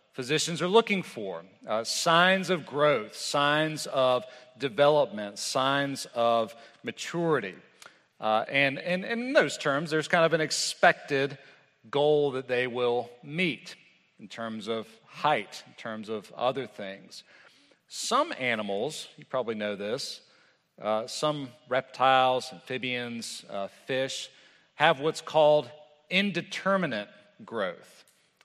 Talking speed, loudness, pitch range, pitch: 120 wpm, -28 LUFS, 115-155 Hz, 135 Hz